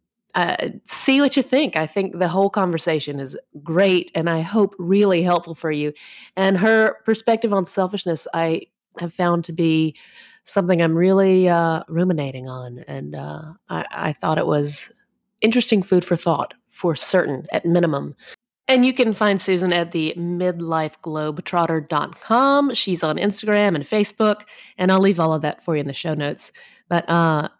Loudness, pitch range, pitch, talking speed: -20 LUFS, 160-205 Hz, 175 Hz, 165 wpm